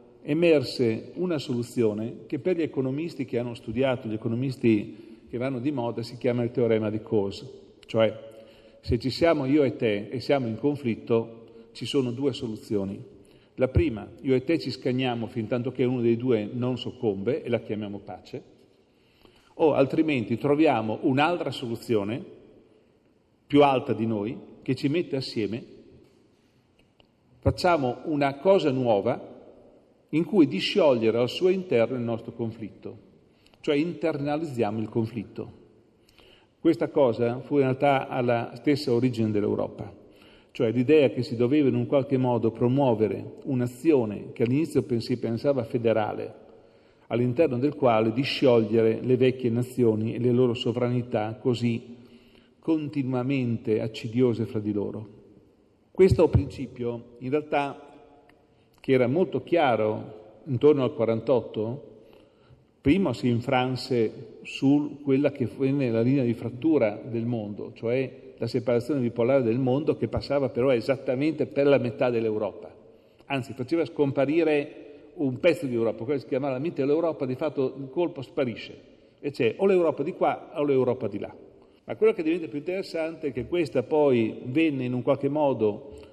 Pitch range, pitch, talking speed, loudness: 115-145 Hz, 125 Hz, 145 wpm, -26 LUFS